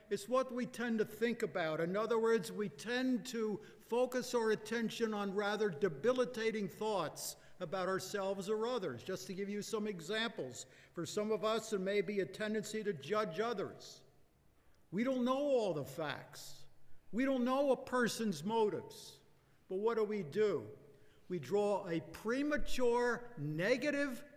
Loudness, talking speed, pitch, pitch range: -38 LUFS, 160 wpm, 215 Hz, 200-240 Hz